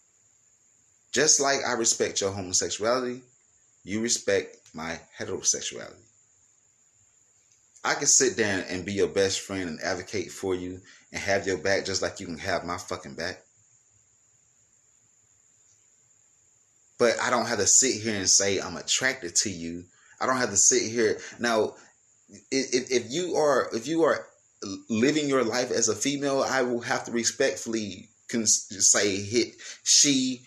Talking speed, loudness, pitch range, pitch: 150 wpm, -25 LUFS, 100-125 Hz, 115 Hz